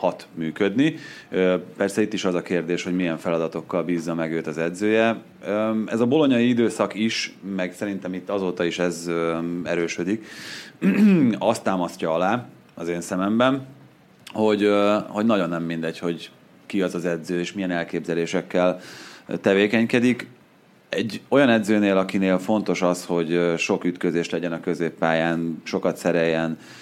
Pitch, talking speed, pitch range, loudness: 90 Hz, 140 wpm, 85-105 Hz, -23 LUFS